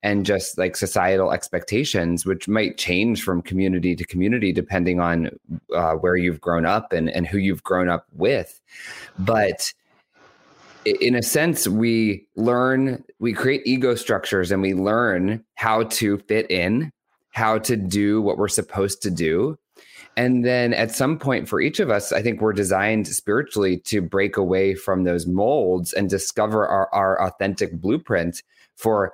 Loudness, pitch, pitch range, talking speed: -21 LUFS, 100 Hz, 95-115 Hz, 160 wpm